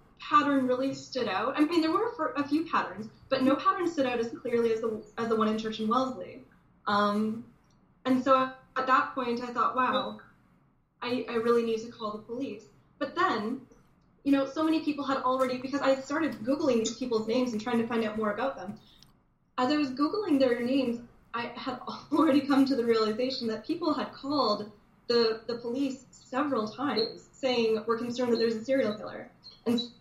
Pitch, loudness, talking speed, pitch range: 255 Hz, -29 LUFS, 200 wpm, 230-275 Hz